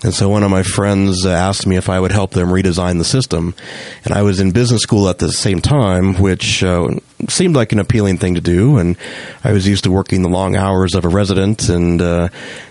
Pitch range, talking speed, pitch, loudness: 90-105 Hz, 230 wpm, 95 Hz, -14 LUFS